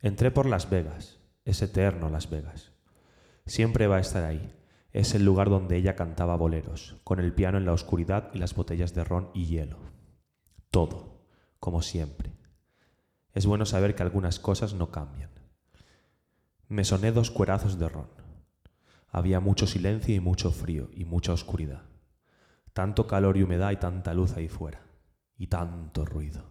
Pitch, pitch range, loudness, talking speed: 90 Hz, 80-100 Hz, -28 LUFS, 160 wpm